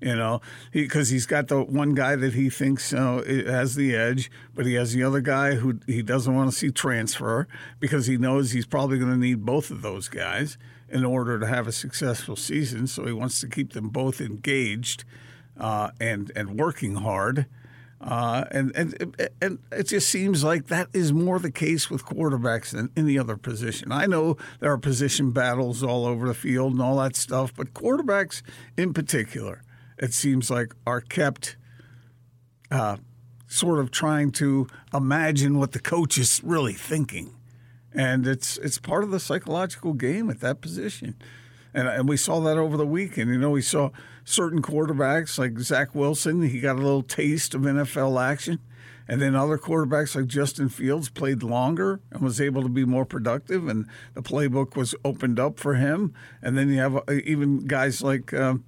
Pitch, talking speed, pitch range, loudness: 130 Hz, 190 wpm, 125-145 Hz, -25 LUFS